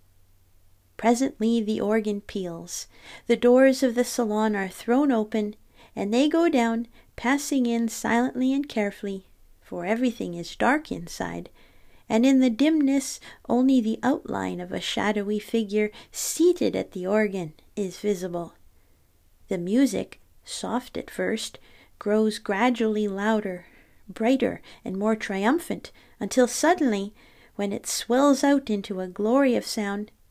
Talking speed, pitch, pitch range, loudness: 130 wpm, 220 Hz, 200-250 Hz, -25 LUFS